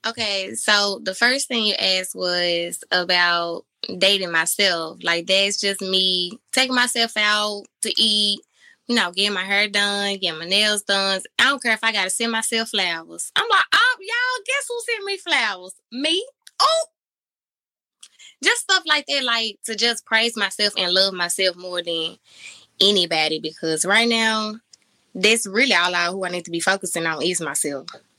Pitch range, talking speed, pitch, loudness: 180-230 Hz, 170 wpm, 200 Hz, -19 LUFS